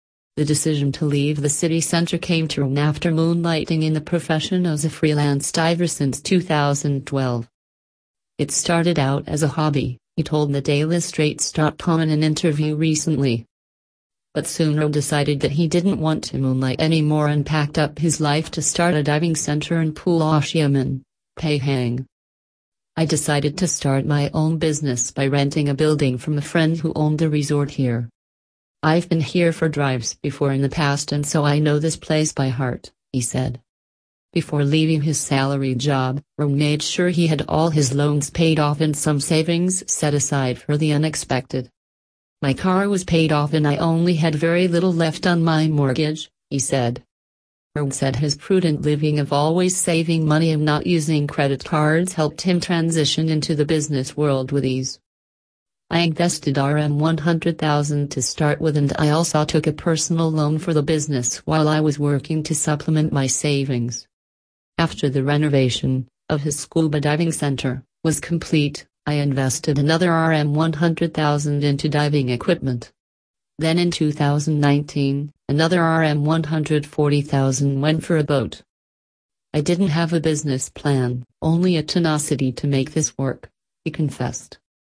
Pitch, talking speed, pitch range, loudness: 150 Hz, 160 wpm, 135-160 Hz, -20 LUFS